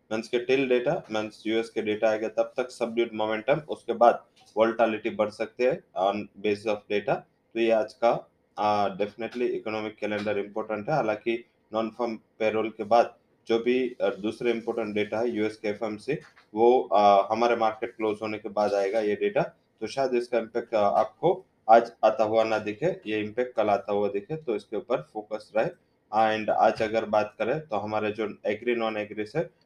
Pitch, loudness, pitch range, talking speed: 110 Hz, -27 LUFS, 105-115 Hz, 180 wpm